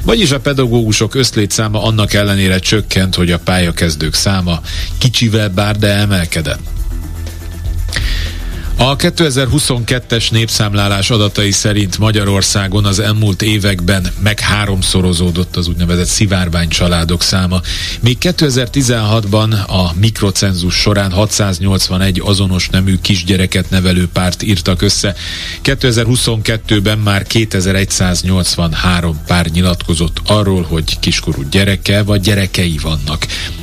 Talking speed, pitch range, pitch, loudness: 100 wpm, 90-110 Hz, 95 Hz, -12 LUFS